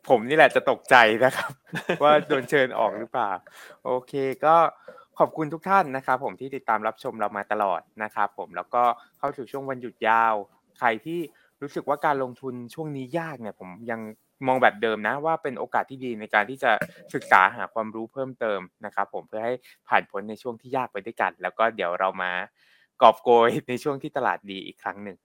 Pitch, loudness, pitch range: 125 Hz, -24 LUFS, 110-140 Hz